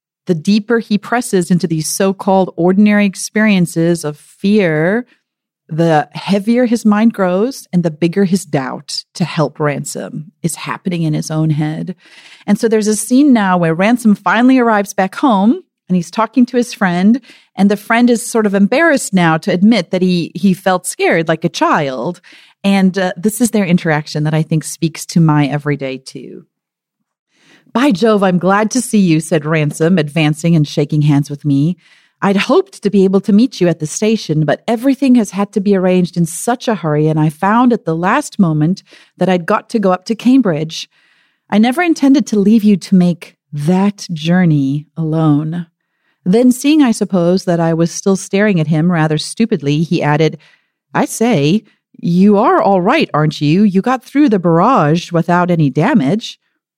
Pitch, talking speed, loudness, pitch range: 185 Hz, 185 wpm, -13 LUFS, 165-220 Hz